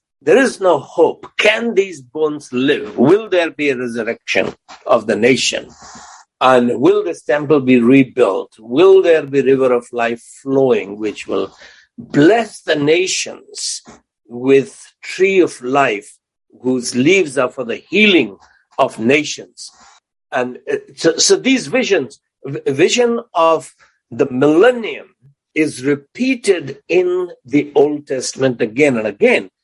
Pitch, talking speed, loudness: 155 Hz, 130 wpm, -15 LUFS